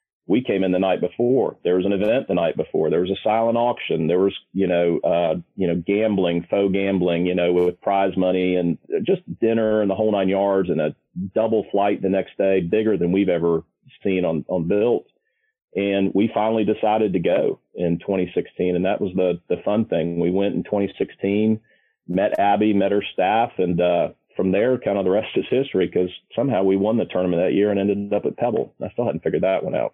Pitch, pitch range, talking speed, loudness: 100 Hz, 90-105 Hz, 220 wpm, -21 LUFS